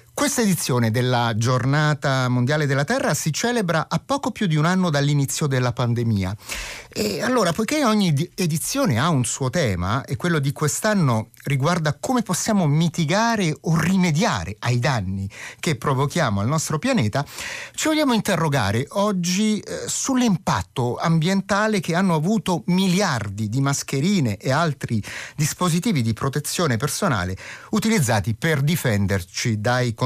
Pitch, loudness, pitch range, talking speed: 150 Hz, -21 LUFS, 125-185 Hz, 135 wpm